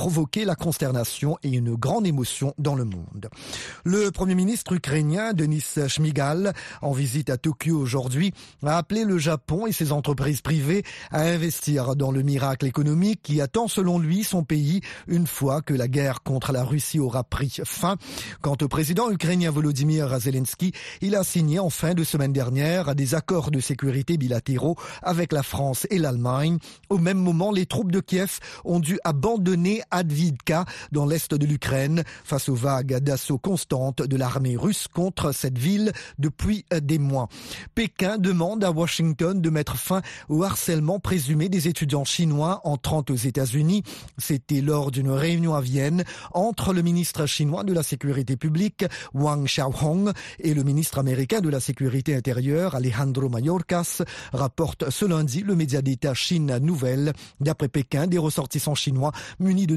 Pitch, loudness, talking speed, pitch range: 155 Hz, -24 LUFS, 165 wpm, 140-175 Hz